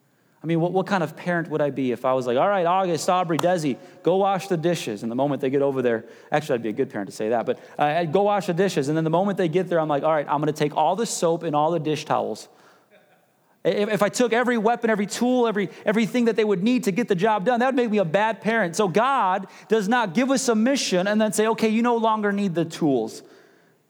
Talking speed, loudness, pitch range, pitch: 285 wpm, -22 LUFS, 155-220 Hz, 190 Hz